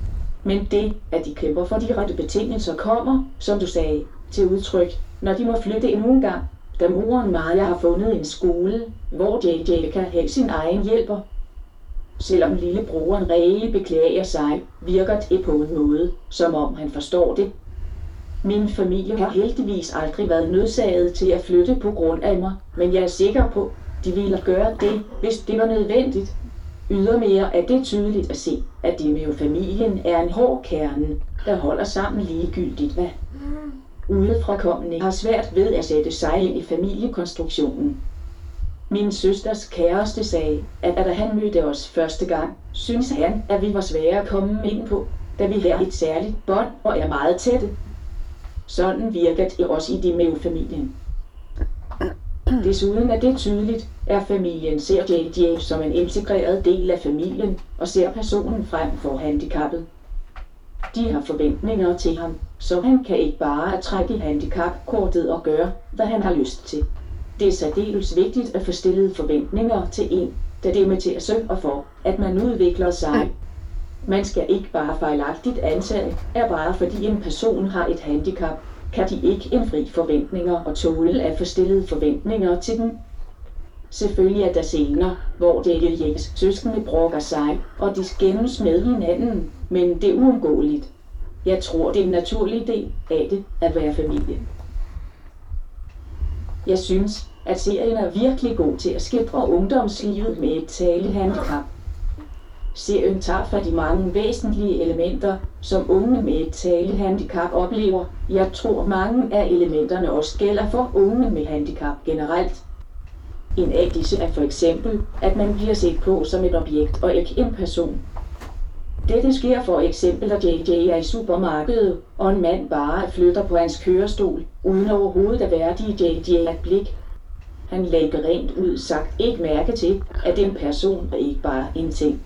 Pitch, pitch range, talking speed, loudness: 180 Hz, 155-205 Hz, 165 wpm, -21 LUFS